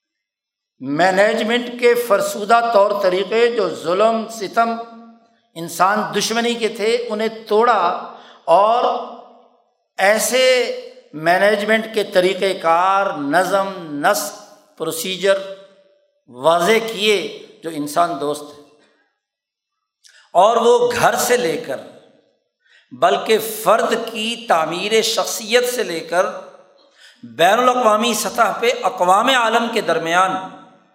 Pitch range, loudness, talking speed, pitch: 185-240 Hz, -17 LUFS, 100 wpm, 220 Hz